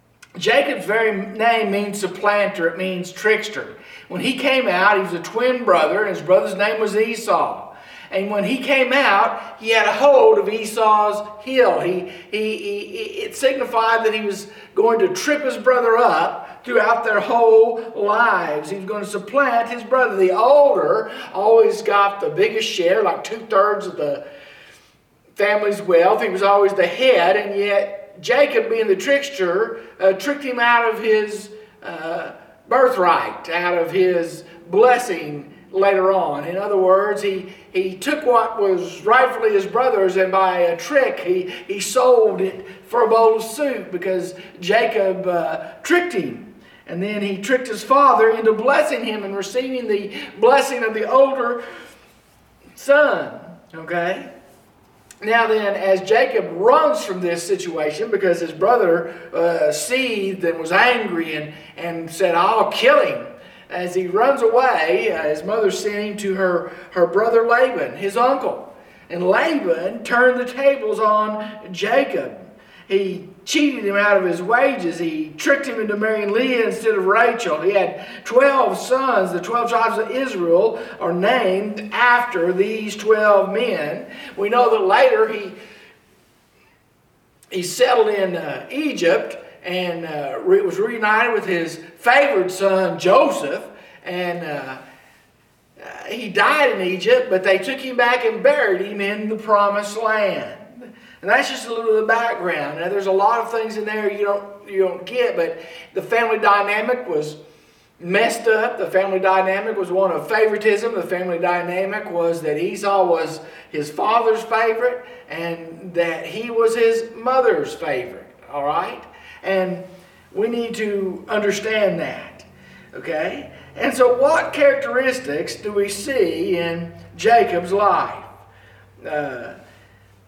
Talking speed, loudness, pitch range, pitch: 150 wpm, -18 LUFS, 185-245 Hz, 210 Hz